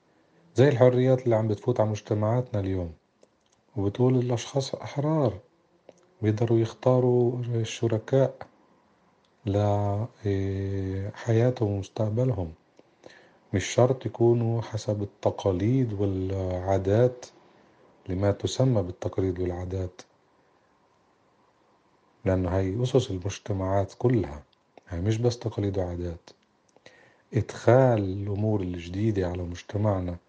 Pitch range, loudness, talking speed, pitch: 95-120 Hz, -26 LUFS, 85 wpm, 105 Hz